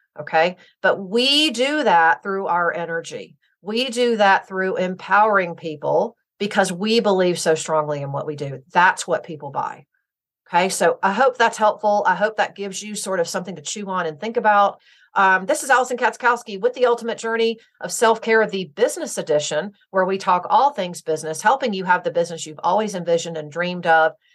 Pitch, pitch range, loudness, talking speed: 195 Hz, 170-225 Hz, -20 LUFS, 195 wpm